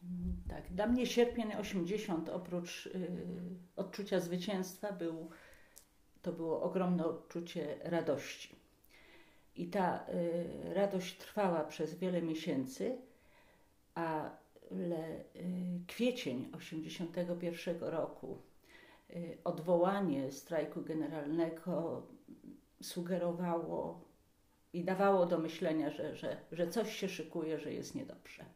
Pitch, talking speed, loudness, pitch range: 175 Hz, 95 wpm, -39 LUFS, 165-190 Hz